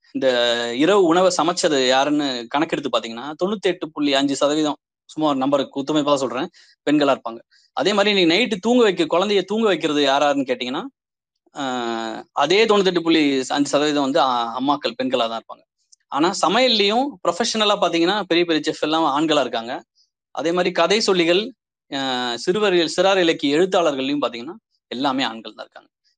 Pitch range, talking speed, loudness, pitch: 135-185 Hz, 145 wpm, -19 LUFS, 155 Hz